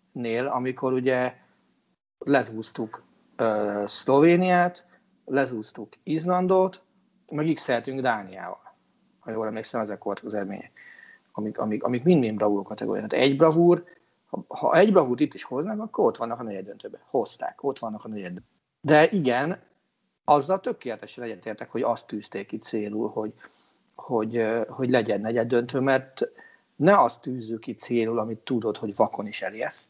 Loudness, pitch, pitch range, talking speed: -25 LUFS, 130 Hz, 110-170 Hz, 145 wpm